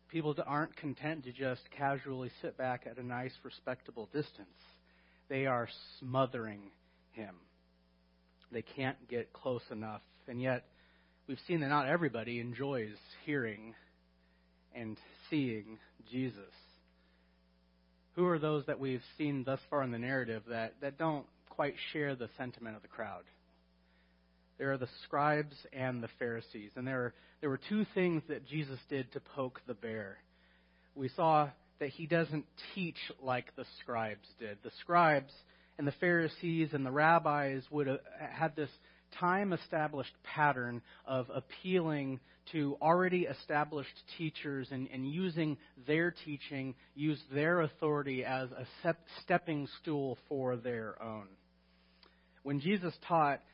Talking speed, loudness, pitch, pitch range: 135 wpm, -37 LUFS, 135 Hz, 110-150 Hz